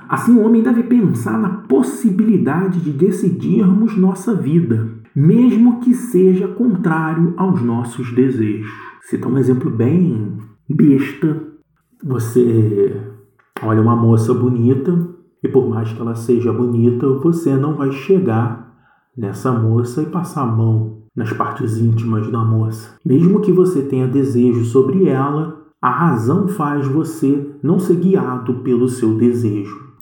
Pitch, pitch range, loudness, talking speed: 135 Hz, 120-180 Hz, -16 LUFS, 135 wpm